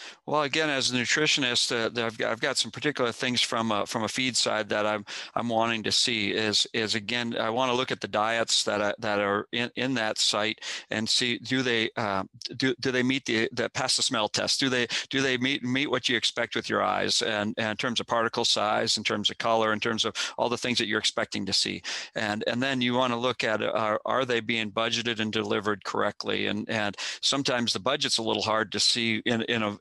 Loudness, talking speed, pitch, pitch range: -26 LUFS, 245 wpm, 115 Hz, 110-125 Hz